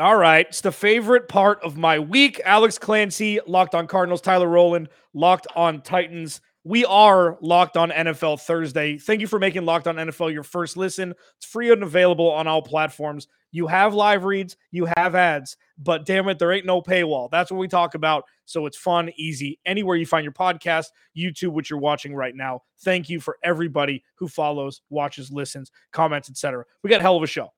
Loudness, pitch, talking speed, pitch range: -20 LUFS, 170 Hz, 200 wpm, 155-185 Hz